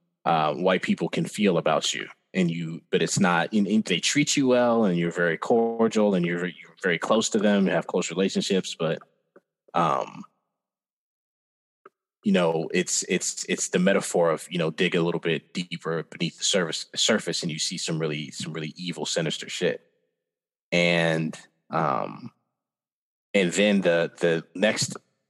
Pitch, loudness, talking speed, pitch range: 85 Hz, -25 LUFS, 170 wpm, 85-115 Hz